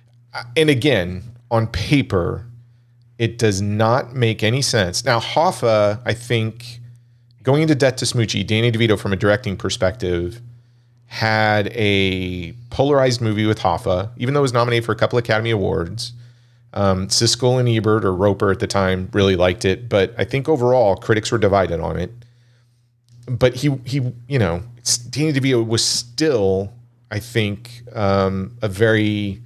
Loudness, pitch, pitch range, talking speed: -18 LUFS, 115 Hz, 100-120 Hz, 155 wpm